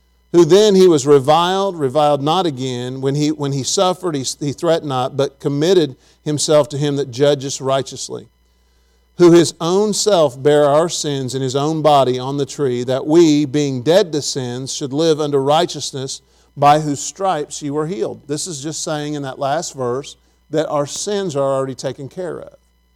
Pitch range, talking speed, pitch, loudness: 135-155 Hz, 185 wpm, 145 Hz, -16 LUFS